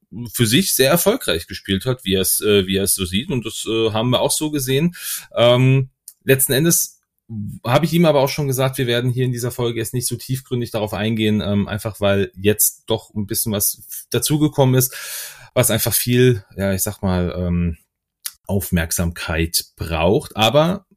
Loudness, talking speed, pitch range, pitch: -18 LUFS, 185 wpm, 100-130 Hz, 115 Hz